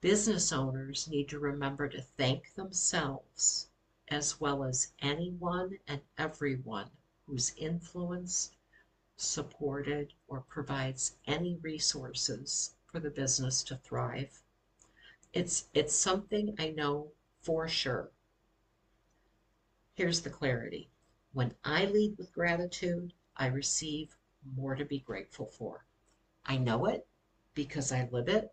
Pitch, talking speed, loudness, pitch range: 145 Hz, 115 wpm, -34 LUFS, 130-160 Hz